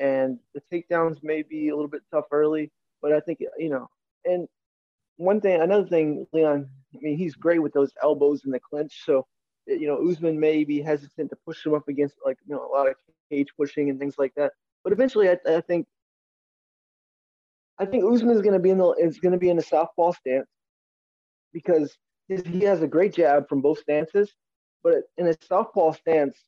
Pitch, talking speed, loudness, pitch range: 155 Hz, 210 wpm, -24 LUFS, 145-175 Hz